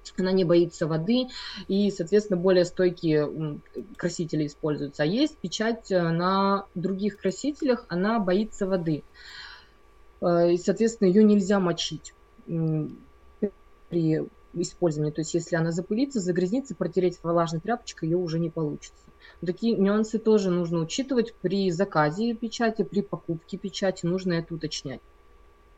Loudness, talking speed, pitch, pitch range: -26 LUFS, 125 wpm, 180 Hz, 165-205 Hz